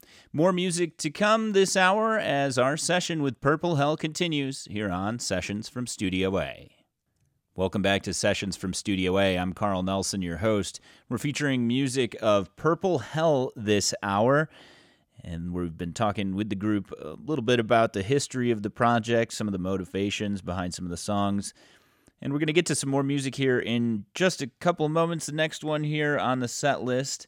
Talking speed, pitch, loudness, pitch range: 190 wpm, 120 Hz, -26 LUFS, 100-150 Hz